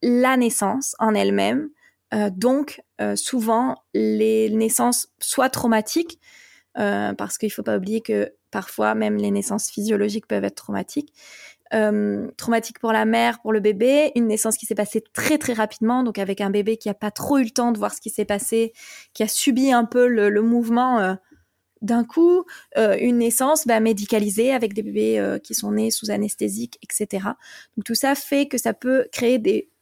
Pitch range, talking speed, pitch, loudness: 210-255 Hz, 195 wpm, 225 Hz, -21 LUFS